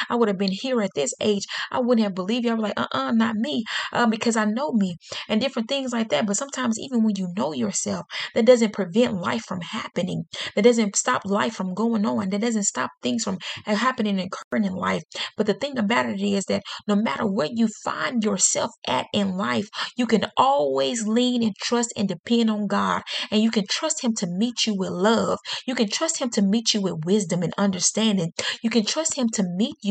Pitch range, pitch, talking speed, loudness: 200-240 Hz, 220 Hz, 230 wpm, -23 LUFS